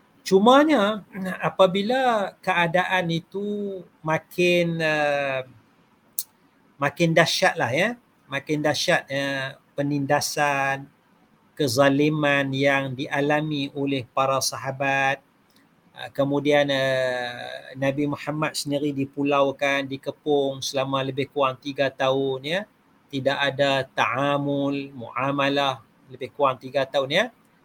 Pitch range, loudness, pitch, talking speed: 135-160 Hz, -23 LUFS, 140 Hz, 95 wpm